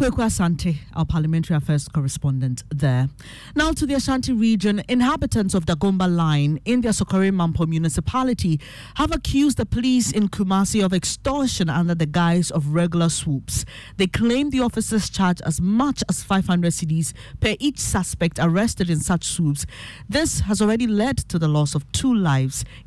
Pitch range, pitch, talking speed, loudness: 155-220 Hz, 175 Hz, 160 wpm, -21 LUFS